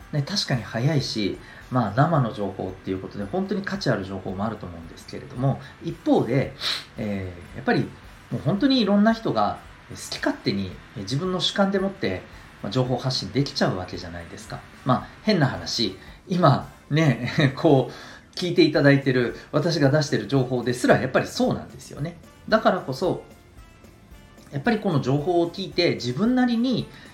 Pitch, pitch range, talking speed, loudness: 130 Hz, 105-170 Hz, 345 characters per minute, -24 LUFS